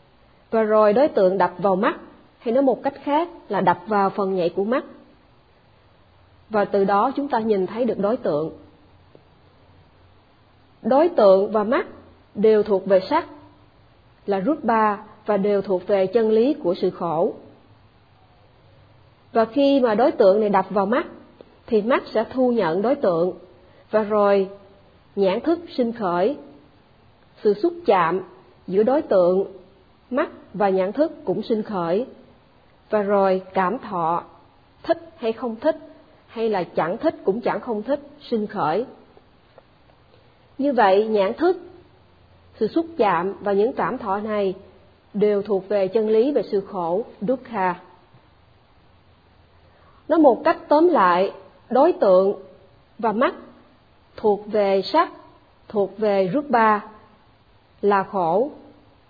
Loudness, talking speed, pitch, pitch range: -21 LUFS, 145 wpm, 210 Hz, 185-260 Hz